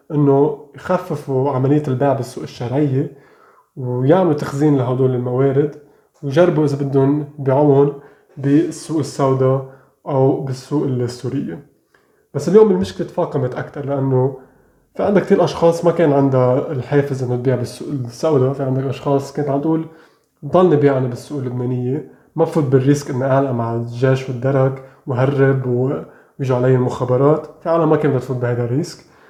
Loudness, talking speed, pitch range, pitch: -17 LUFS, 135 wpm, 130-150 Hz, 140 Hz